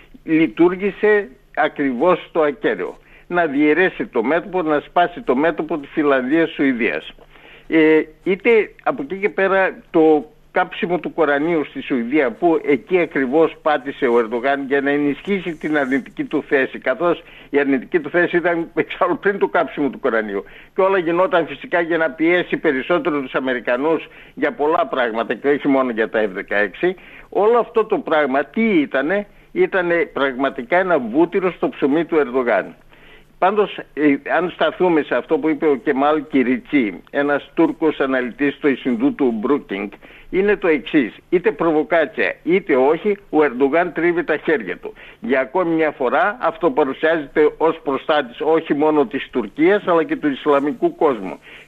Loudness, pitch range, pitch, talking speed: -18 LUFS, 145-190 Hz, 165 Hz, 155 wpm